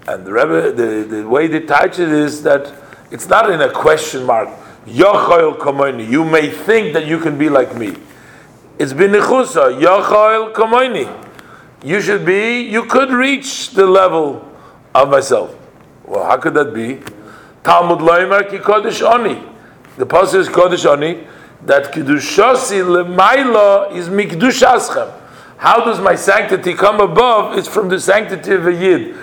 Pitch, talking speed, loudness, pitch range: 190 Hz, 130 wpm, -12 LUFS, 160-220 Hz